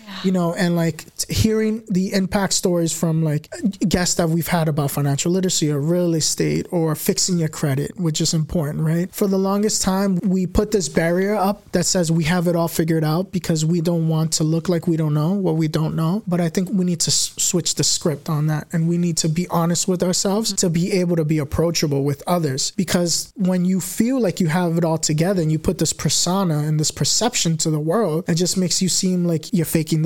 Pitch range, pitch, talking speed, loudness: 160-185 Hz, 175 Hz, 230 wpm, -19 LUFS